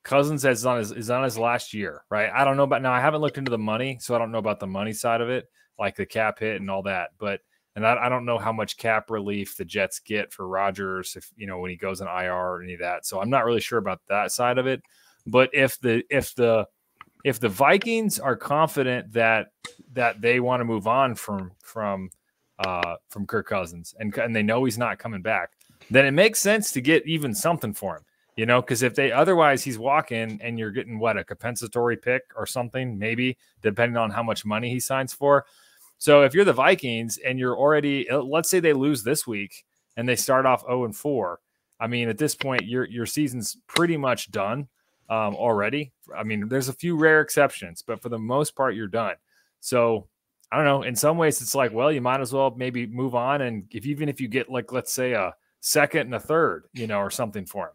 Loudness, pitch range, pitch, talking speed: -24 LUFS, 110-135 Hz, 125 Hz, 235 wpm